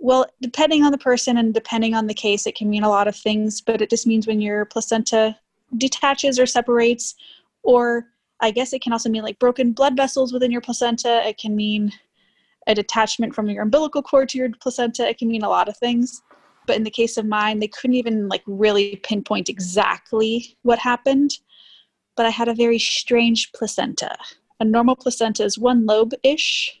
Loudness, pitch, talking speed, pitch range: -20 LUFS, 230 Hz, 195 wpm, 215-250 Hz